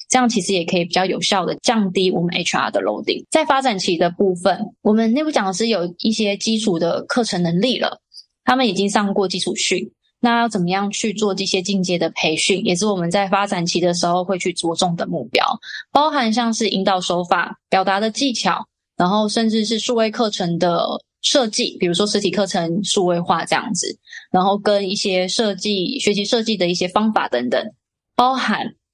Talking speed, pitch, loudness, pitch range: 310 characters per minute, 200 Hz, -18 LUFS, 185-225 Hz